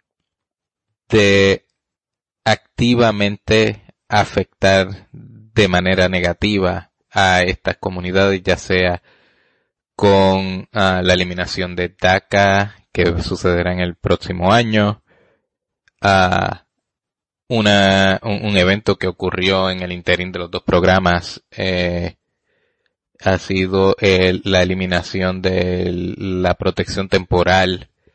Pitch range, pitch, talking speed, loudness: 90-100 Hz, 95 Hz, 105 wpm, -16 LUFS